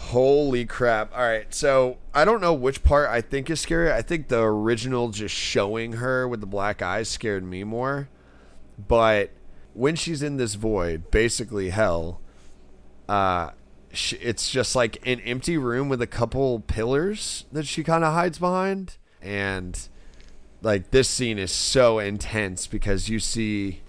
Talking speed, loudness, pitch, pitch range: 160 wpm, -24 LUFS, 110 Hz, 95-130 Hz